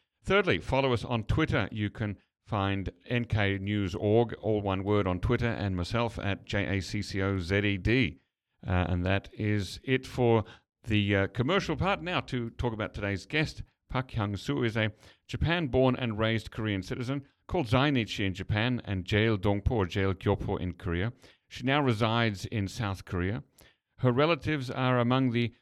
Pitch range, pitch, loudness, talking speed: 100-125 Hz, 110 Hz, -30 LUFS, 155 wpm